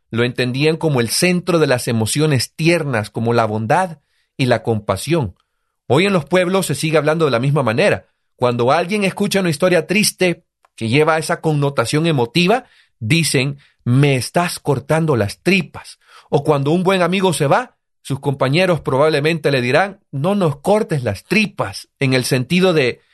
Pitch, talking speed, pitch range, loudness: 155 Hz, 165 wpm, 130-175 Hz, -17 LUFS